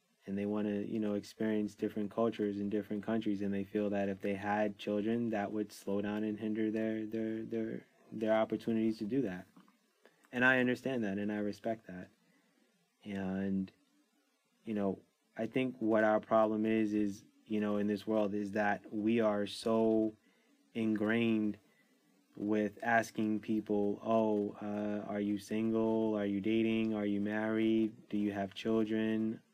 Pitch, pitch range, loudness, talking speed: 105 Hz, 105-110 Hz, -35 LUFS, 165 wpm